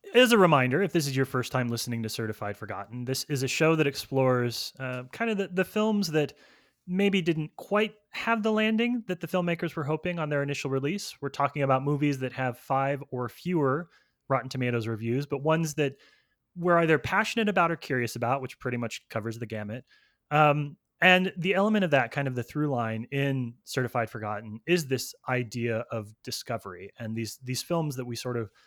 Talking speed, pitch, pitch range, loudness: 200 wpm, 140 Hz, 120-170 Hz, -28 LUFS